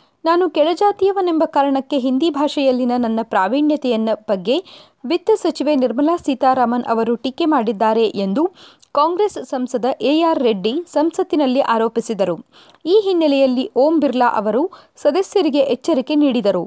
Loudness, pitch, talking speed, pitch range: -17 LUFS, 280 Hz, 110 wpm, 240-325 Hz